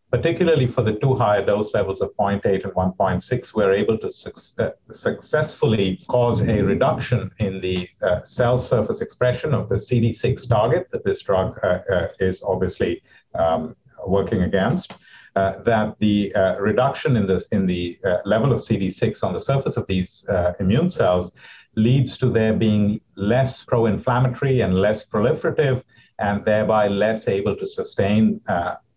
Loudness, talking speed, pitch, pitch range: -21 LUFS, 155 wpm, 110 Hz, 95-125 Hz